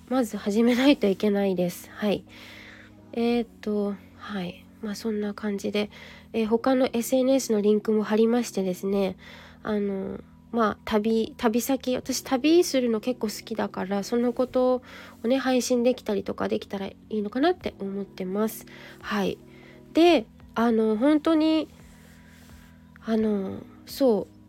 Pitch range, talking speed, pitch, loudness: 200-255 Hz, 260 characters per minute, 220 Hz, -25 LUFS